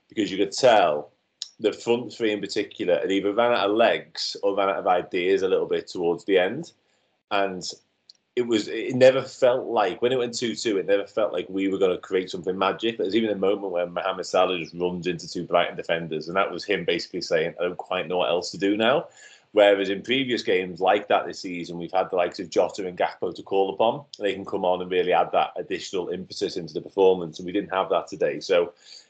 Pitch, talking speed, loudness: 105 Hz, 240 wpm, -24 LUFS